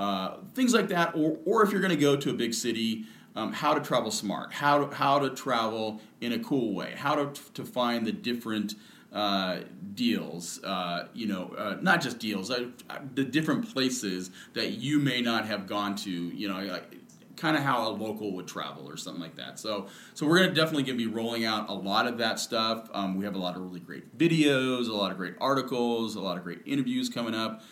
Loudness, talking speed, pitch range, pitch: -29 LUFS, 225 wpm, 105-145 Hz, 115 Hz